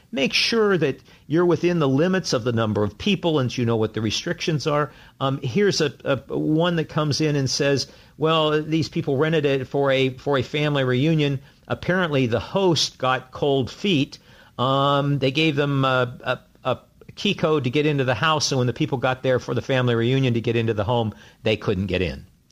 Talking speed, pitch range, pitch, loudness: 210 wpm, 125-155 Hz, 140 Hz, -22 LUFS